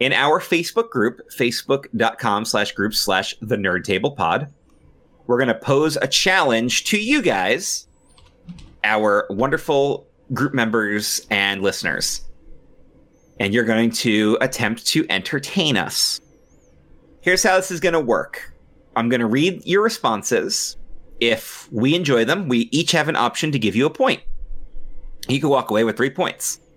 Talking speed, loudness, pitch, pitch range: 155 wpm, -19 LUFS, 130 Hz, 110-170 Hz